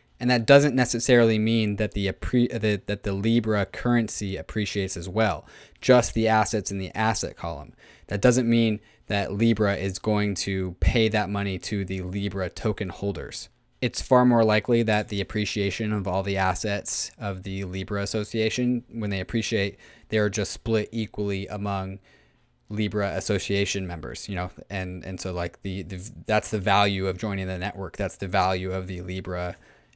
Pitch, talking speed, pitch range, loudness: 100 Hz, 170 wpm, 95-110 Hz, -25 LUFS